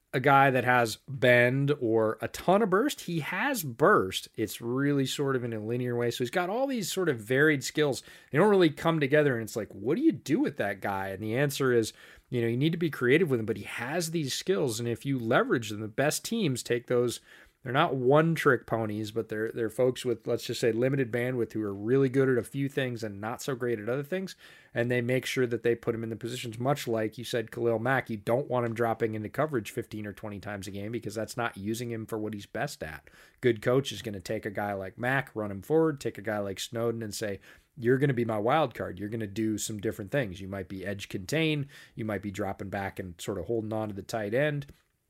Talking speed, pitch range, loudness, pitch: 260 wpm, 110-135 Hz, -29 LUFS, 120 Hz